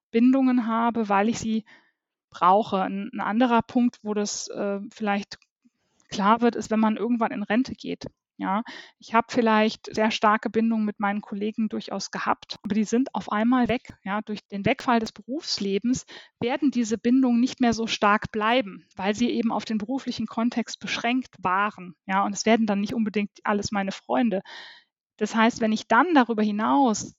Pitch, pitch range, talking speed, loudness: 220 Hz, 210-240 Hz, 180 wpm, -24 LUFS